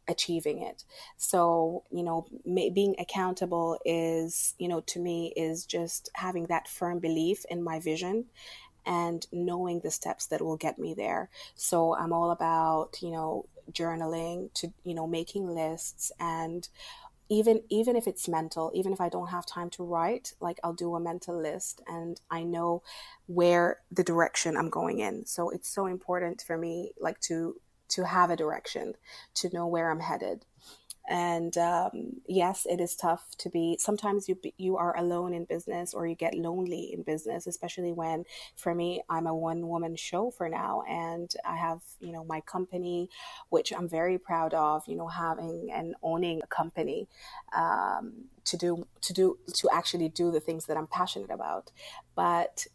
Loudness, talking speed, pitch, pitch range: -31 LUFS, 175 wpm, 170 Hz, 165-180 Hz